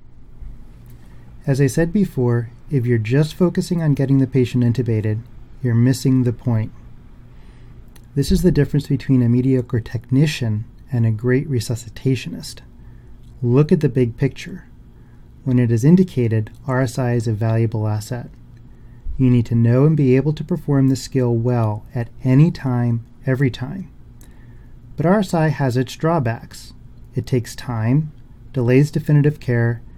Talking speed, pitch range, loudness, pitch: 140 wpm, 120-140 Hz, -19 LUFS, 125 Hz